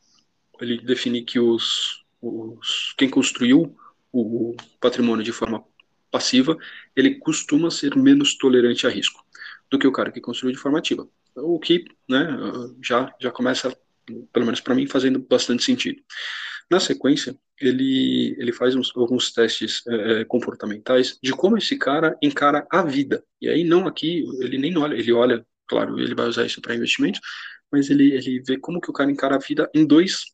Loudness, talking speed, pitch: -21 LUFS, 170 wpm, 135 Hz